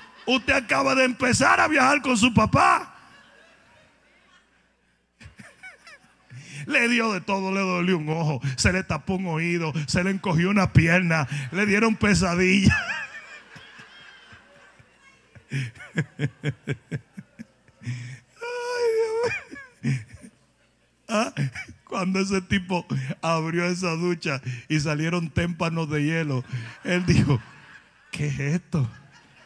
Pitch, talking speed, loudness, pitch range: 165 Hz, 95 wpm, -23 LUFS, 140-195 Hz